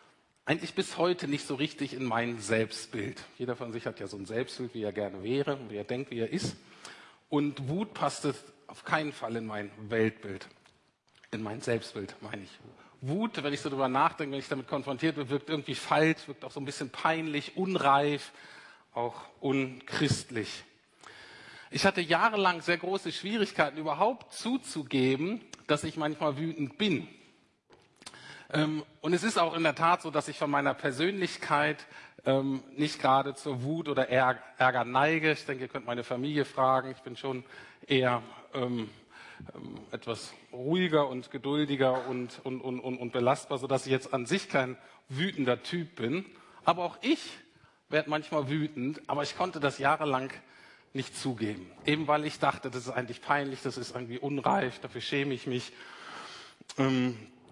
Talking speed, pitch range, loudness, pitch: 165 wpm, 130-155 Hz, -31 LUFS, 140 Hz